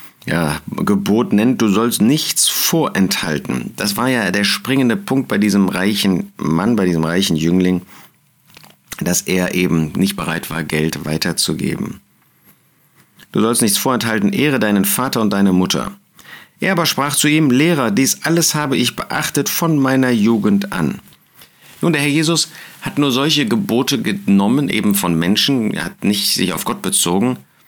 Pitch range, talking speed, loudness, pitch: 90-135 Hz, 160 wpm, -16 LUFS, 105 Hz